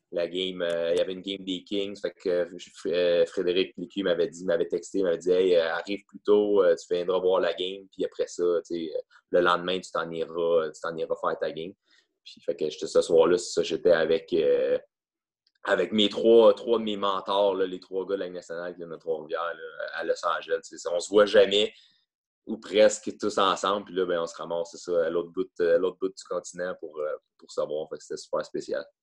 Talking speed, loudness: 230 wpm, -26 LUFS